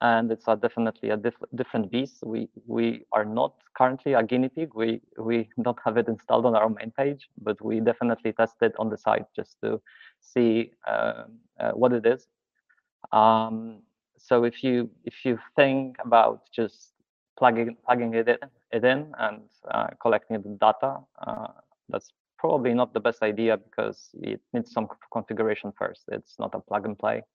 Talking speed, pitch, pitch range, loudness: 180 wpm, 115 Hz, 110-125 Hz, -26 LUFS